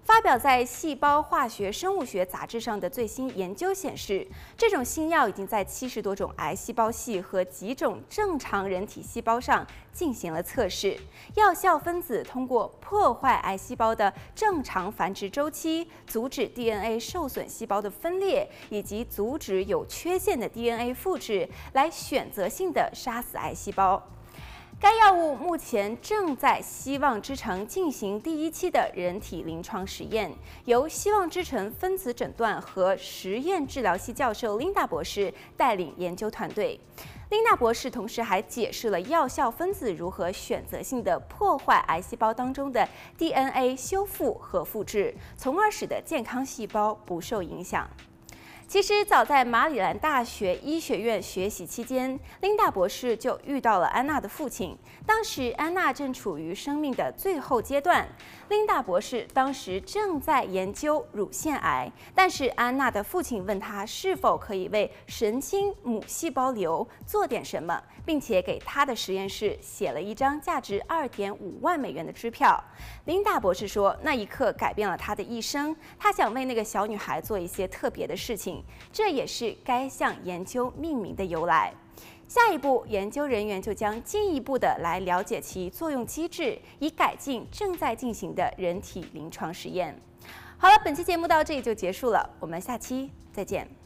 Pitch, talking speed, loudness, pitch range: 255 Hz, 255 characters per minute, -27 LUFS, 210-335 Hz